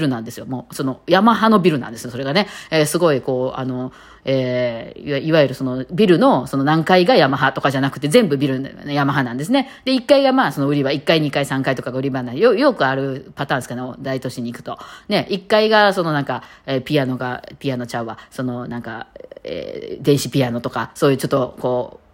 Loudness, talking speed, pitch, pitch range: -18 LUFS, 430 characters per minute, 140 Hz, 130-165 Hz